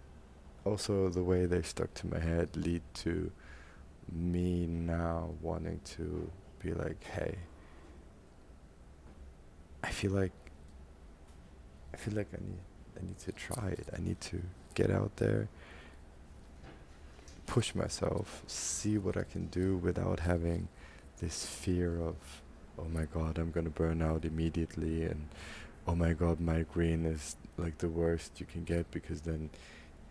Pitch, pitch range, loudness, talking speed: 85 Hz, 75-90 Hz, -36 LUFS, 140 wpm